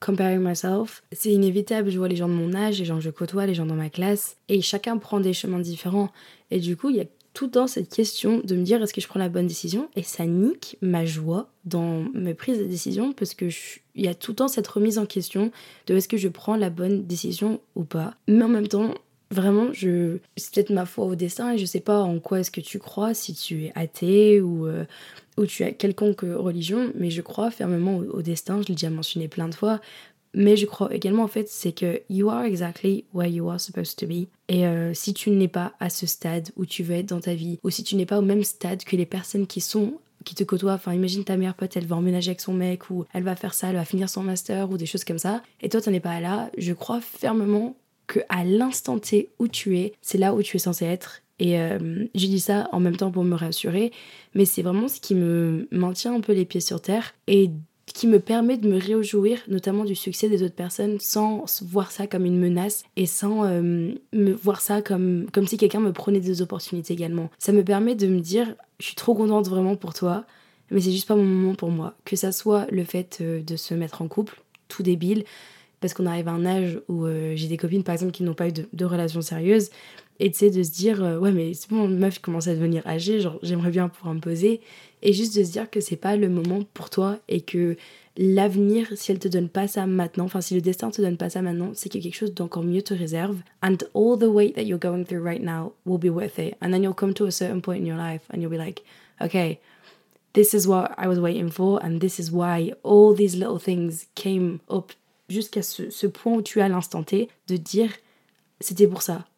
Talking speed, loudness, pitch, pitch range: 250 wpm, -24 LUFS, 190 Hz, 175-210 Hz